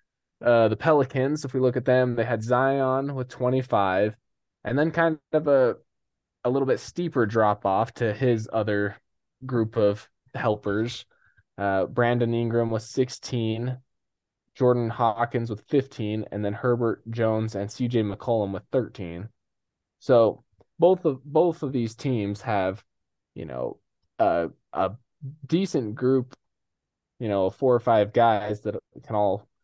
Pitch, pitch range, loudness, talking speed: 115 Hz, 105-130 Hz, -25 LUFS, 150 wpm